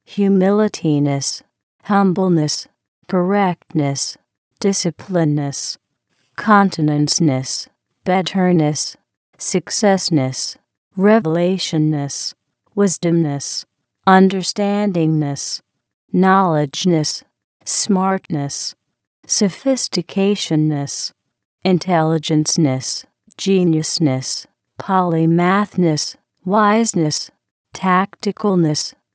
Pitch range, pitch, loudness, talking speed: 155-195 Hz, 175 Hz, -17 LUFS, 35 wpm